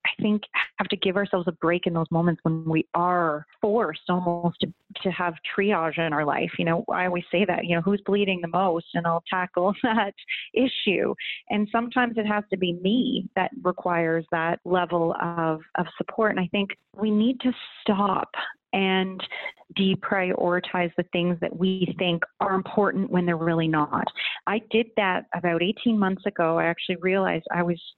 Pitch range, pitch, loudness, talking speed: 170-205 Hz, 185 Hz, -25 LUFS, 185 wpm